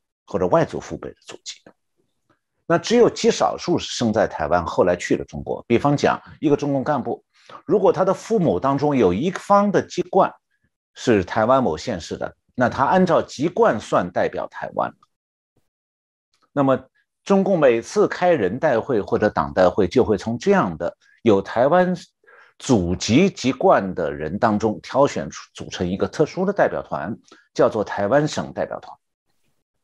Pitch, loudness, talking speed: 140 Hz, -20 LUFS, 240 characters per minute